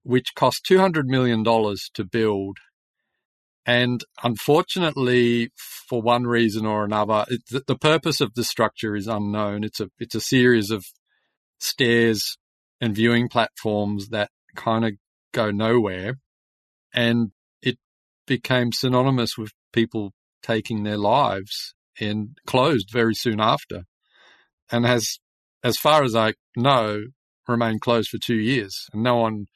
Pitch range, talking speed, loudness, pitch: 105-125 Hz, 135 wpm, -22 LUFS, 115 Hz